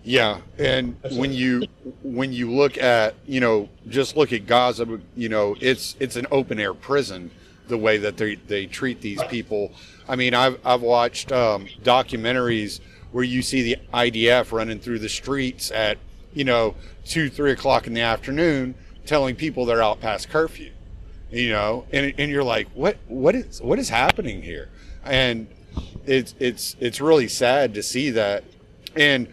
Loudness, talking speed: -22 LUFS, 170 wpm